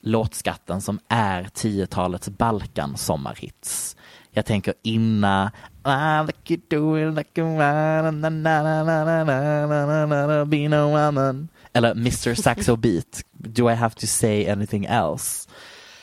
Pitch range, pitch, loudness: 110-150 Hz, 120 Hz, -22 LUFS